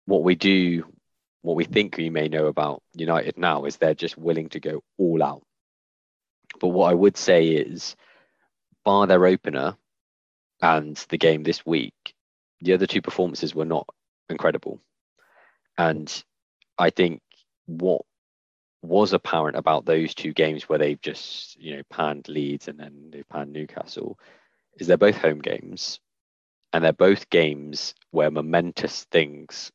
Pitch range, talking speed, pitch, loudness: 75-85 Hz, 150 wpm, 80 Hz, -23 LUFS